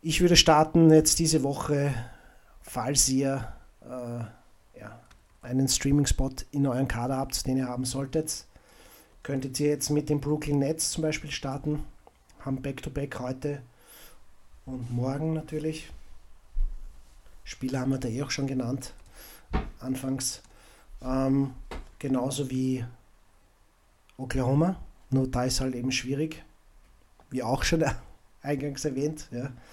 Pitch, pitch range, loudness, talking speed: 135 Hz, 125-145 Hz, -28 LUFS, 125 wpm